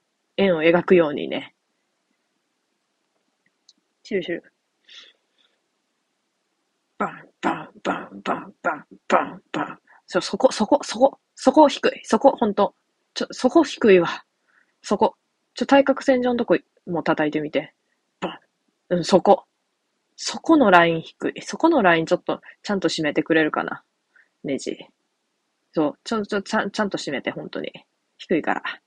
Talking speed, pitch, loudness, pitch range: 270 characters per minute, 205 Hz, -21 LUFS, 170-270 Hz